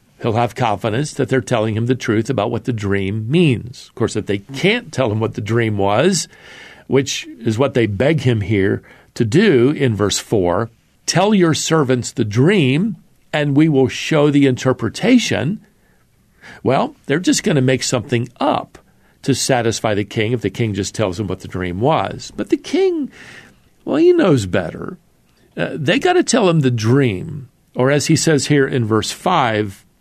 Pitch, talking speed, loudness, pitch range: 130 Hz, 185 wpm, -17 LUFS, 110-160 Hz